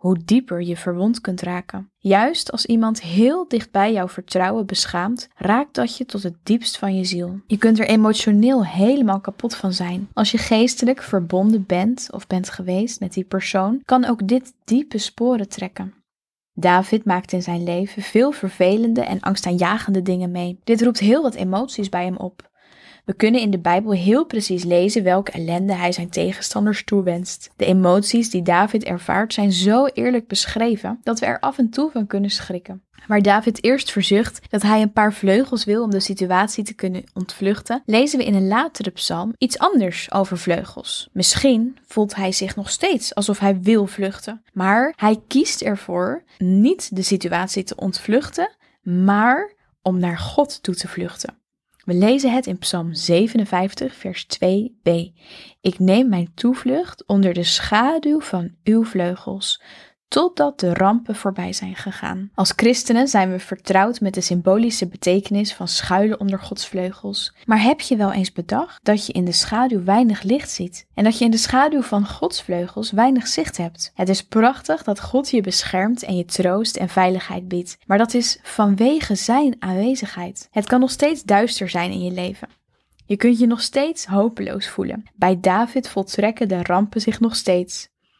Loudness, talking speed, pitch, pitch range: -19 LUFS, 175 wpm, 205 Hz, 185-235 Hz